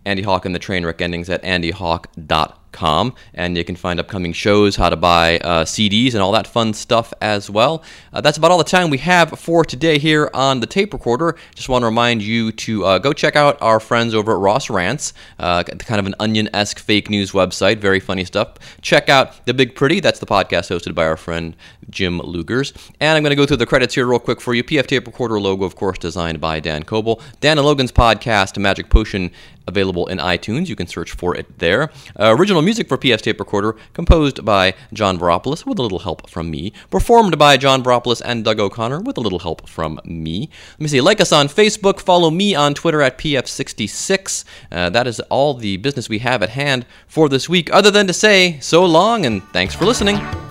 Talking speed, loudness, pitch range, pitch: 220 wpm, -16 LUFS, 95-145 Hz, 115 Hz